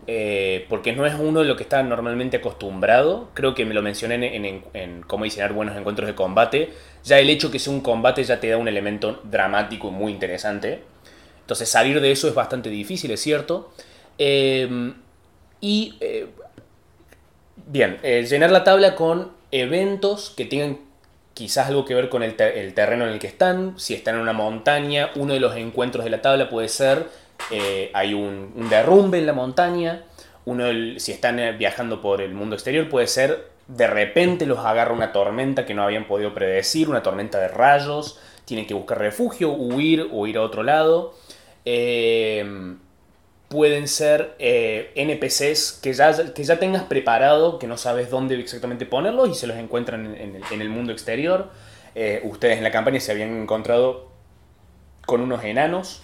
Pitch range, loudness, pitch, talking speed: 105-150 Hz, -21 LUFS, 125 Hz, 185 wpm